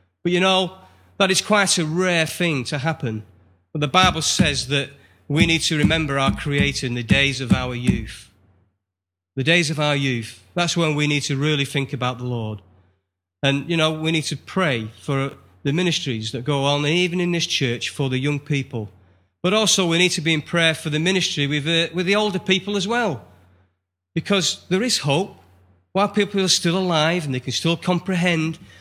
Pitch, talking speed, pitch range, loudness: 150 Hz, 200 wpm, 120-175 Hz, -20 LUFS